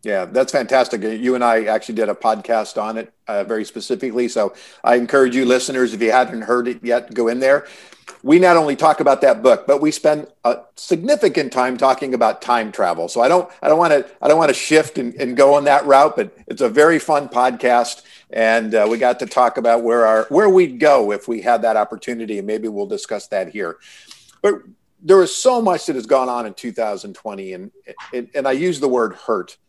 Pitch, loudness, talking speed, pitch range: 125 Hz, -17 LUFS, 230 wpm, 115-145 Hz